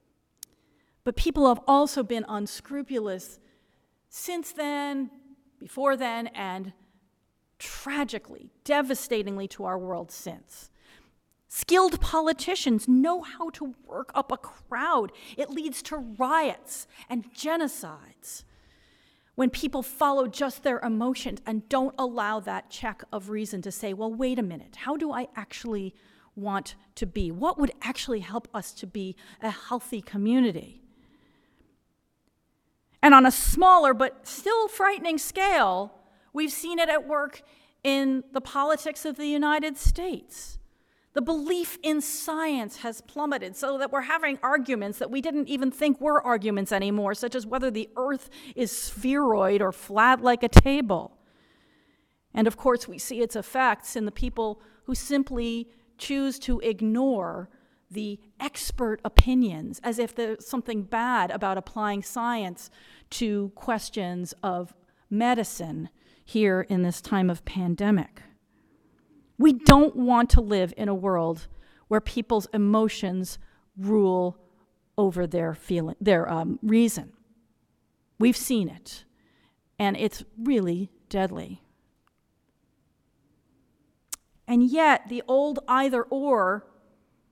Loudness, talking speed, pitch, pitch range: -26 LUFS, 130 wpm, 240 Hz, 210-275 Hz